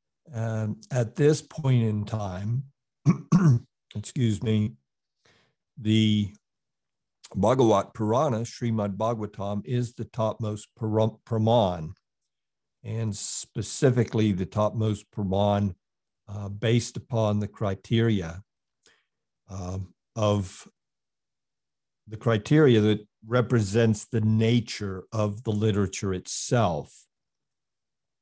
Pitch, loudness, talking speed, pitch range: 110 Hz, -26 LUFS, 85 wpm, 105-115 Hz